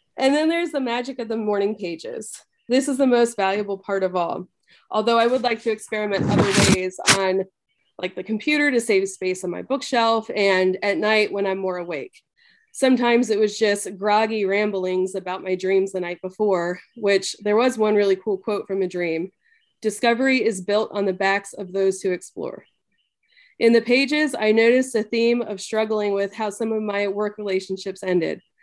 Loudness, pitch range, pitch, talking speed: -21 LUFS, 190-235 Hz, 210 Hz, 190 wpm